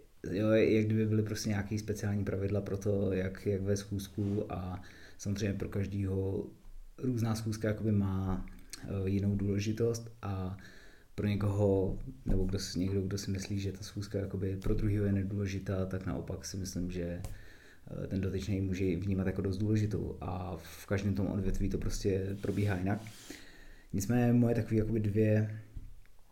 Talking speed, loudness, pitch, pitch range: 155 wpm, -34 LUFS, 100 Hz, 95-105 Hz